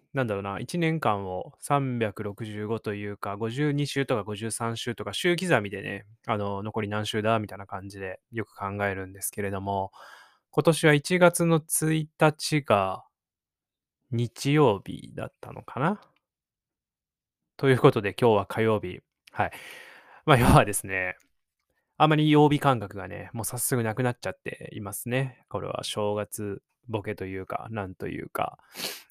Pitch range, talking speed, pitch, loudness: 100-145 Hz, 265 characters per minute, 115 Hz, -27 LUFS